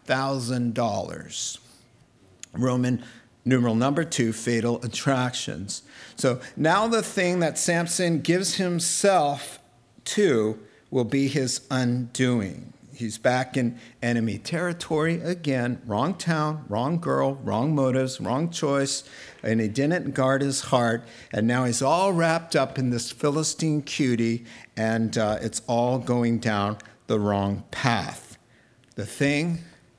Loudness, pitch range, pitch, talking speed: -25 LUFS, 115-150 Hz, 130 Hz, 125 wpm